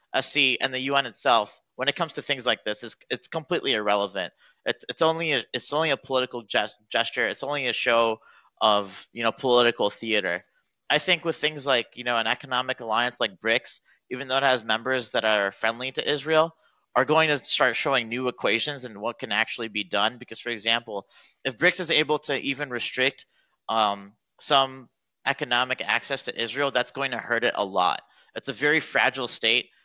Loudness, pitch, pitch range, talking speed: -24 LUFS, 125 Hz, 115-140 Hz, 195 wpm